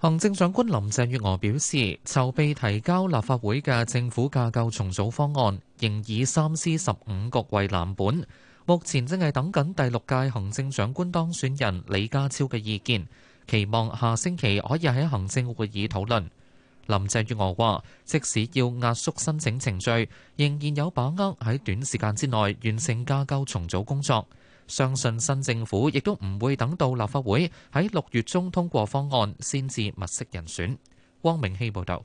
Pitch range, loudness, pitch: 105-140 Hz, -26 LUFS, 125 Hz